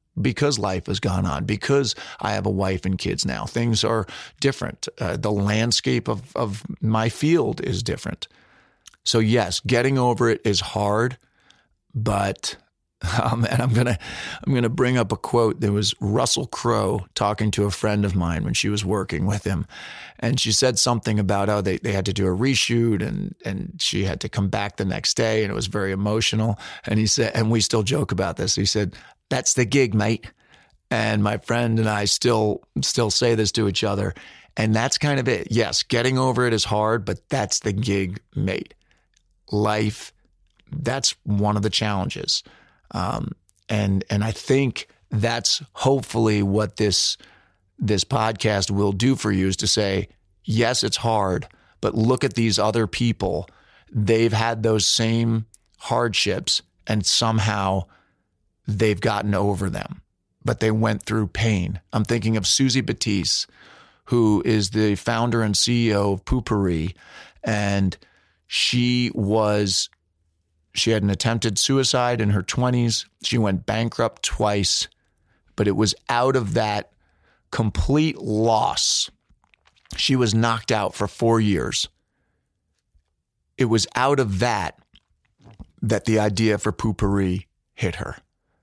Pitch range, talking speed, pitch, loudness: 100-115 Hz, 160 wpm, 110 Hz, -22 LUFS